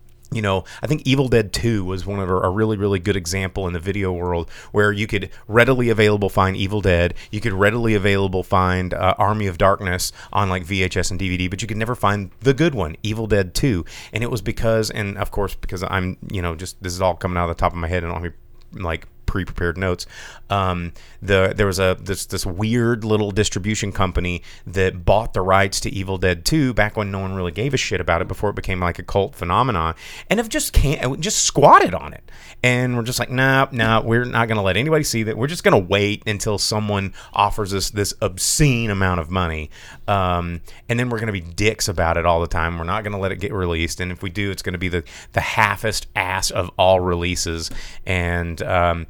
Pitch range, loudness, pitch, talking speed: 90-110 Hz, -20 LUFS, 100 Hz, 230 wpm